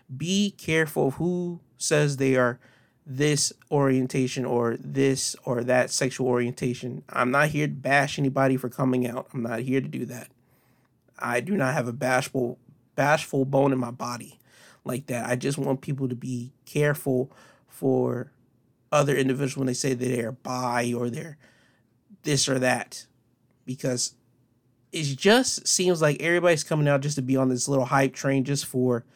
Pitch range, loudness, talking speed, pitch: 125-140 Hz, -25 LUFS, 170 wpm, 130 Hz